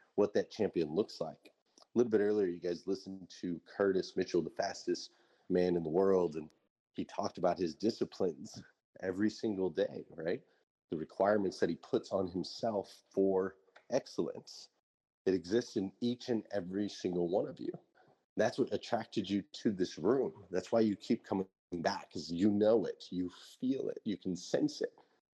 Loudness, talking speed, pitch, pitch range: -36 LUFS, 175 wpm, 95 Hz, 90-115 Hz